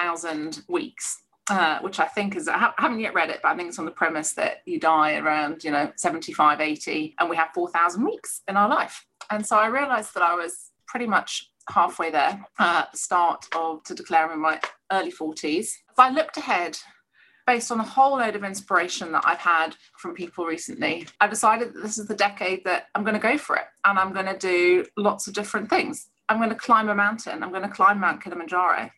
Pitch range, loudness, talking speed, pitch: 165-220 Hz, -23 LUFS, 230 wpm, 195 Hz